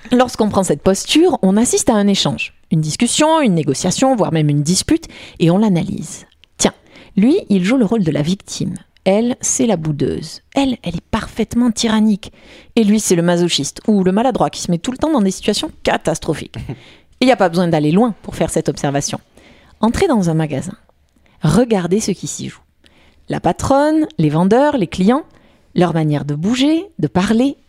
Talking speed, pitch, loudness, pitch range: 190 wpm, 200 Hz, -16 LUFS, 170-245 Hz